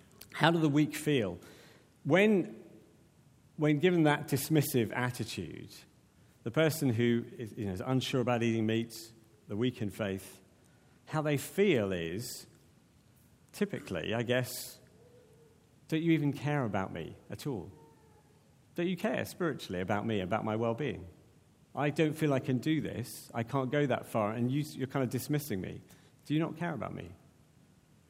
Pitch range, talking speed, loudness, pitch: 115-150 Hz, 160 wpm, -32 LUFS, 130 Hz